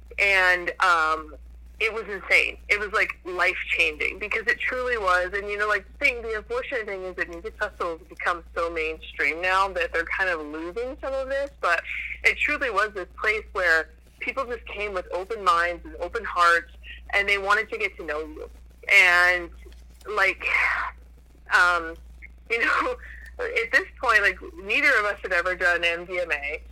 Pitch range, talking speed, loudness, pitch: 170-260 Hz, 180 wpm, -23 LUFS, 200 Hz